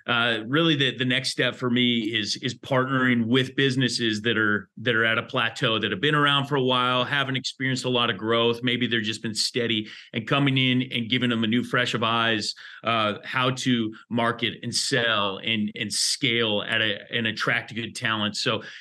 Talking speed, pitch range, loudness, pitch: 205 wpm, 115-130 Hz, -23 LUFS, 120 Hz